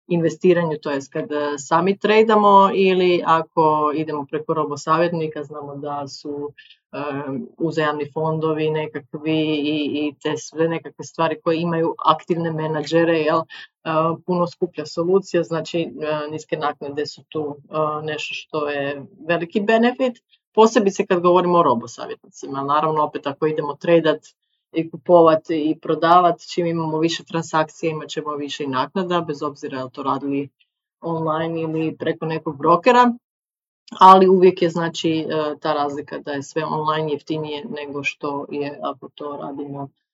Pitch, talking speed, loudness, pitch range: 155 Hz, 140 wpm, -20 LUFS, 150-170 Hz